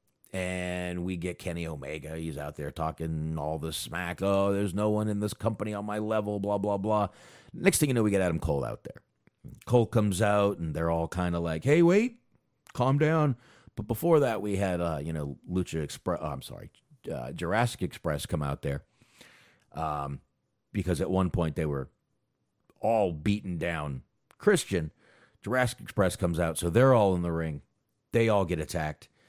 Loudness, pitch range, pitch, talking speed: -29 LUFS, 80-110 Hz, 95 Hz, 190 wpm